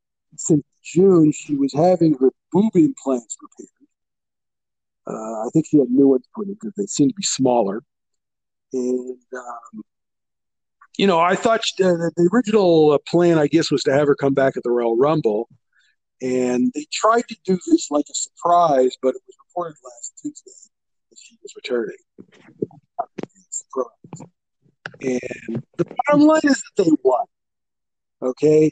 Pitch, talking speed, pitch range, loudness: 160 Hz, 155 wpm, 130-200 Hz, -19 LUFS